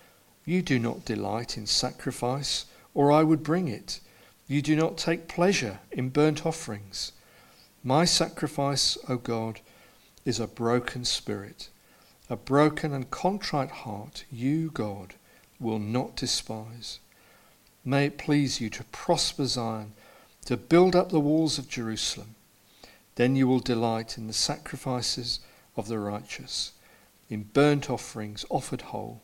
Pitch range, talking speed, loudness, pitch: 110-145 Hz, 140 wpm, -28 LUFS, 125 Hz